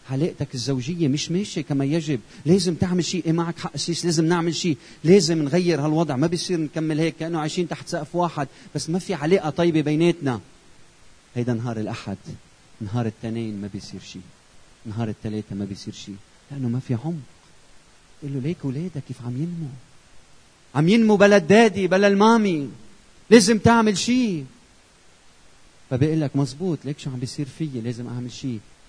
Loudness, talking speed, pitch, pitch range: -22 LUFS, 160 wpm, 150 Hz, 125-175 Hz